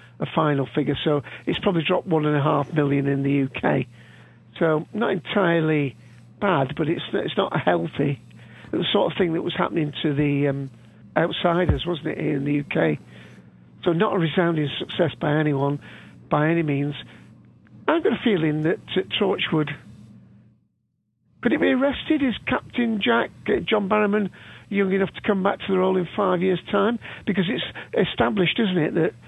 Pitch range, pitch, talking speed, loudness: 145-195 Hz, 160 Hz, 180 wpm, -23 LUFS